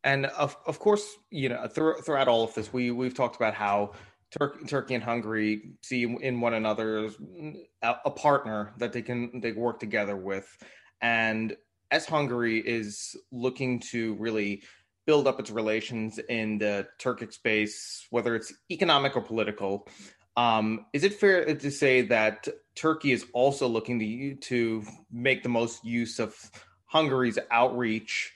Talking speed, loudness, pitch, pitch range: 155 wpm, -28 LUFS, 120 Hz, 110-135 Hz